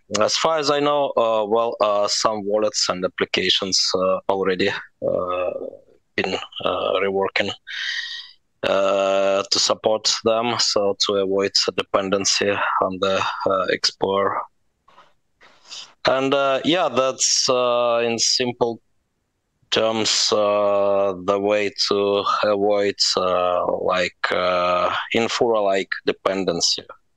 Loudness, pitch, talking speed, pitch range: -20 LUFS, 105 Hz, 110 wpm, 100-120 Hz